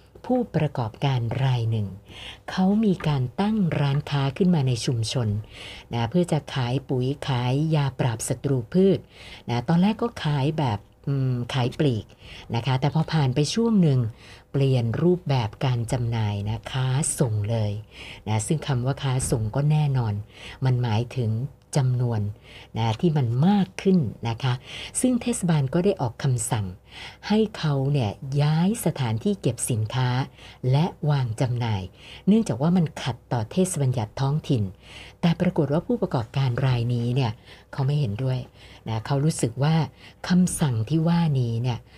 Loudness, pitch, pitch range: -24 LUFS, 135 Hz, 115-155 Hz